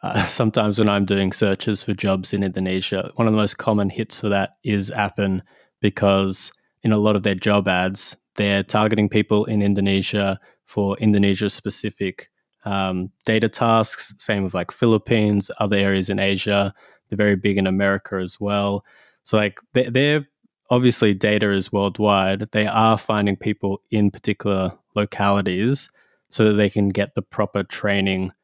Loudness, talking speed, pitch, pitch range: -20 LUFS, 160 wpm, 100 Hz, 100-110 Hz